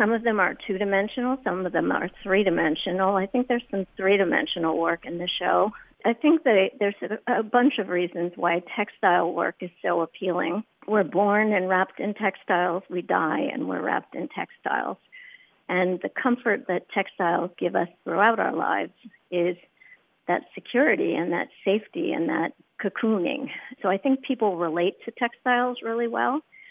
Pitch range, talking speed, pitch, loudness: 180-235 Hz, 175 wpm, 200 Hz, -25 LUFS